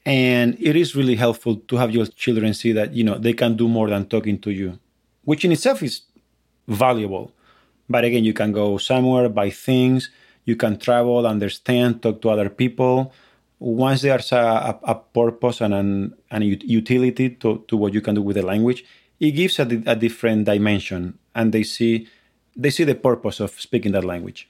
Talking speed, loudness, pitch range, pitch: 190 wpm, -20 LUFS, 105-125 Hz, 115 Hz